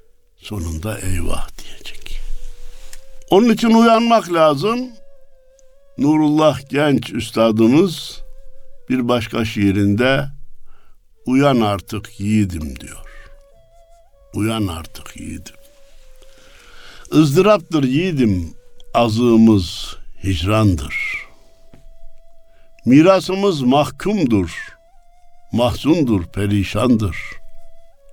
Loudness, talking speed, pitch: -16 LUFS, 60 wpm, 145 Hz